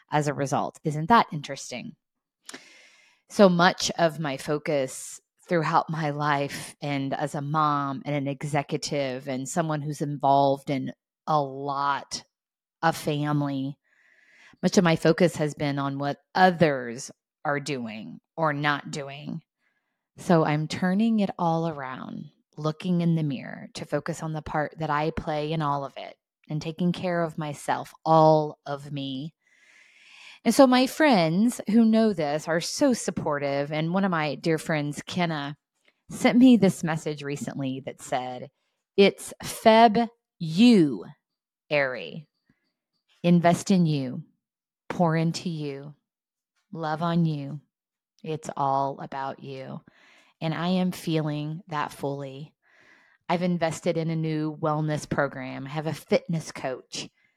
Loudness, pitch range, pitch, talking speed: -25 LUFS, 145-180 Hz, 155 Hz, 140 wpm